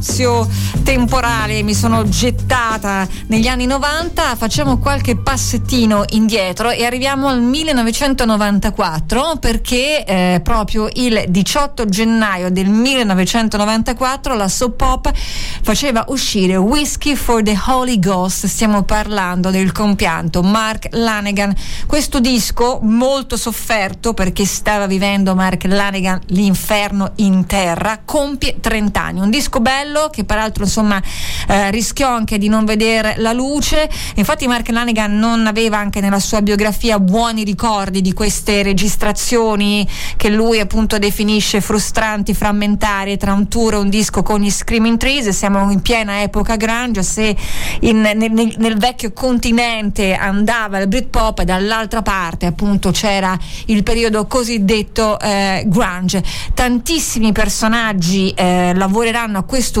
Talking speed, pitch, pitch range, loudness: 130 wpm, 215 Hz, 195-230 Hz, -15 LUFS